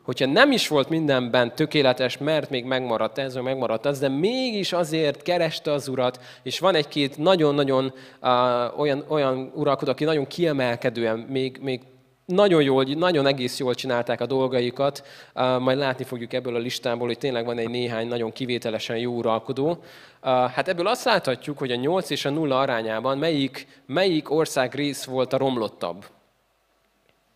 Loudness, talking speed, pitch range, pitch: -24 LUFS, 165 wpm, 125-145 Hz, 135 Hz